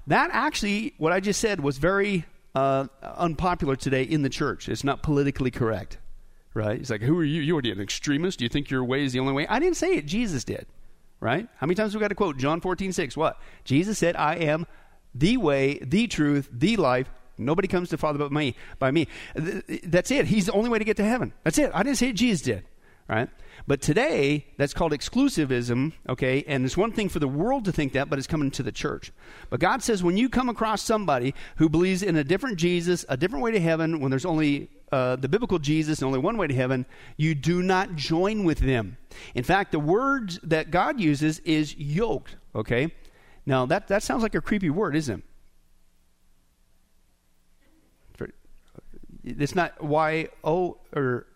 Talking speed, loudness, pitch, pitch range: 205 wpm, -25 LUFS, 155 Hz, 135-185 Hz